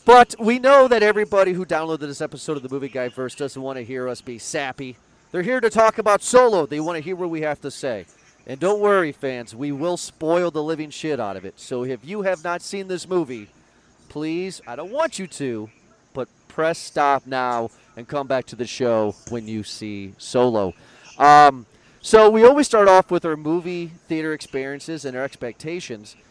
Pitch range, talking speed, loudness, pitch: 125-180 Hz, 210 wpm, -20 LUFS, 150 Hz